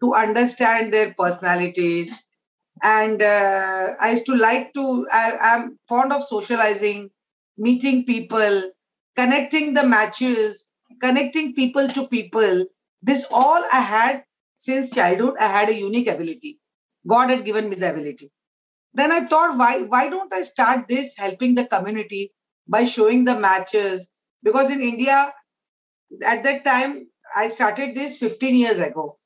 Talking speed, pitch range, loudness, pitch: 145 wpm, 210-265 Hz, -19 LUFS, 235 Hz